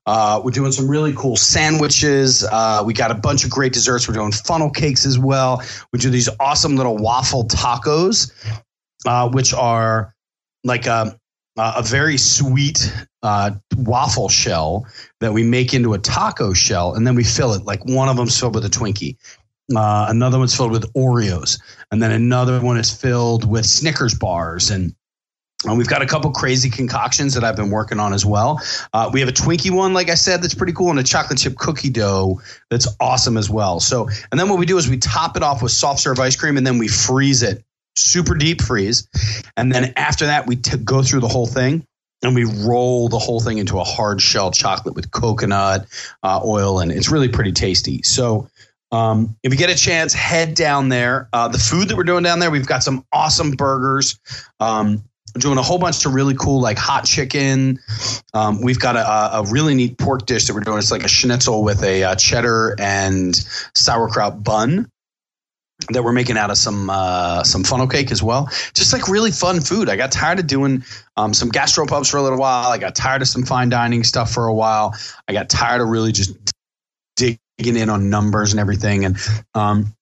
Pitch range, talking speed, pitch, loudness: 110-135 Hz, 210 wpm, 120 Hz, -16 LUFS